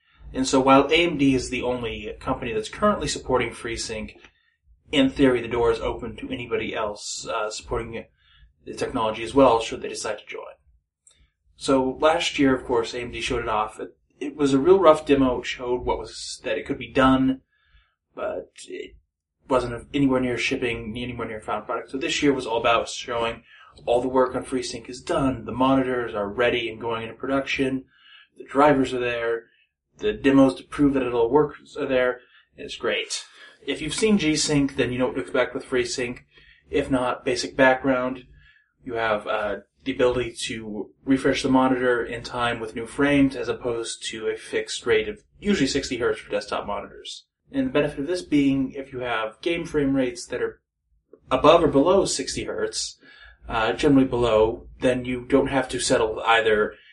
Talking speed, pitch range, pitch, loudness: 190 wpm, 115-140 Hz, 130 Hz, -23 LUFS